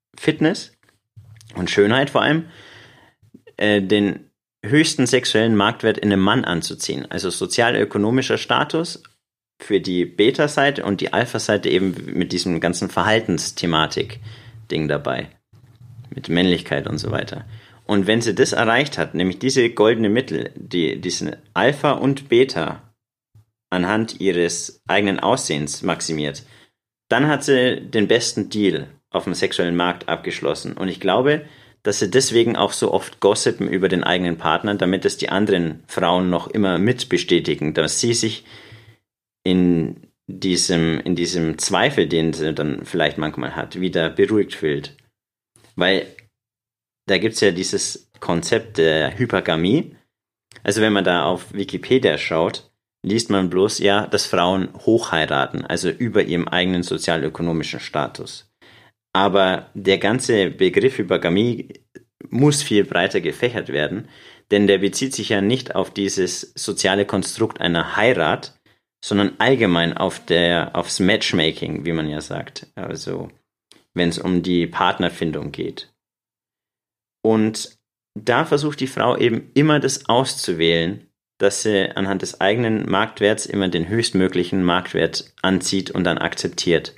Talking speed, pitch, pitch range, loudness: 135 wpm, 100 Hz, 90-115 Hz, -19 LUFS